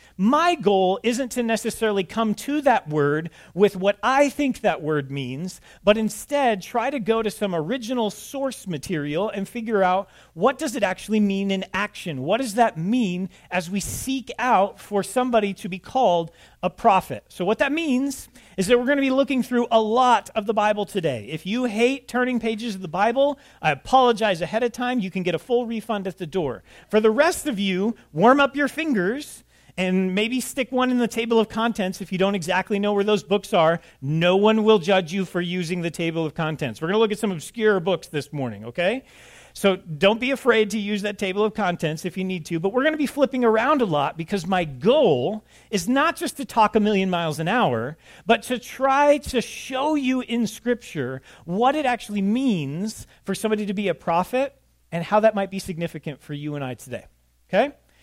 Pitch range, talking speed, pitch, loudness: 180-245 Hz, 215 wpm, 210 Hz, -22 LUFS